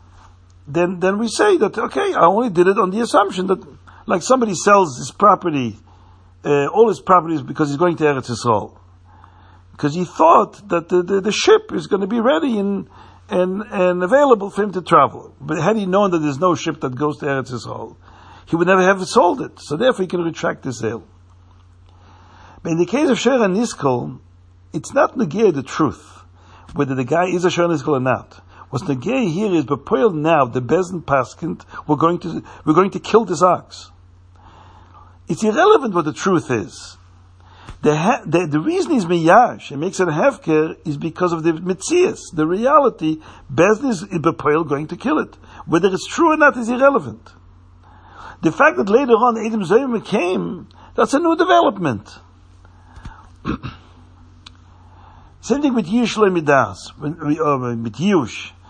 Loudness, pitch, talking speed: -17 LUFS, 160 Hz, 175 wpm